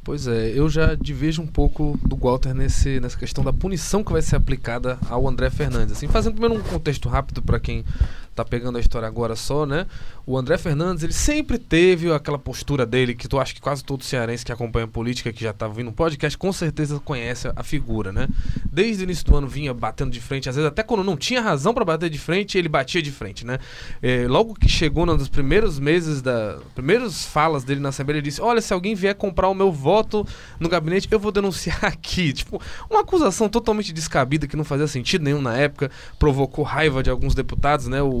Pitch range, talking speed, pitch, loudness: 125-175 Hz, 220 wpm, 145 Hz, -22 LUFS